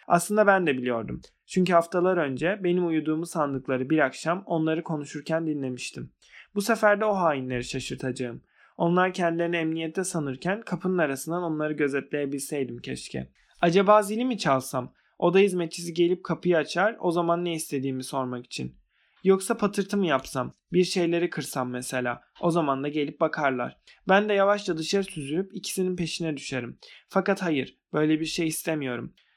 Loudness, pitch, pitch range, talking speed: -26 LUFS, 165 Hz, 140-180 Hz, 150 wpm